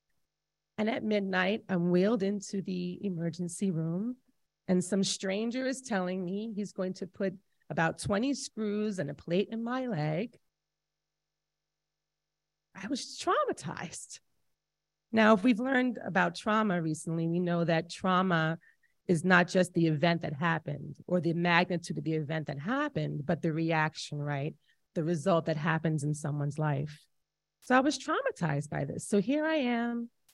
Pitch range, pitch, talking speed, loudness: 155-210 Hz, 180 Hz, 155 wpm, -31 LUFS